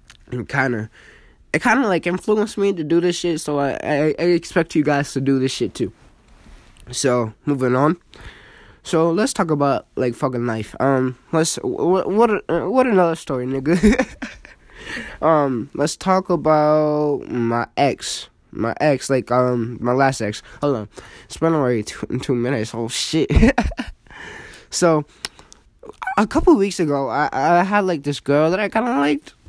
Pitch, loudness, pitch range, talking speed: 145 Hz, -19 LUFS, 130-175 Hz, 165 wpm